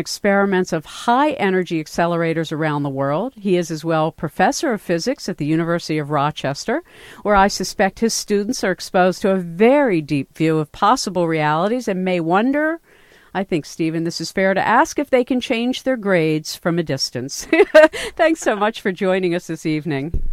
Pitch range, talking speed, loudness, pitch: 160-230 Hz, 185 wpm, -19 LUFS, 185 Hz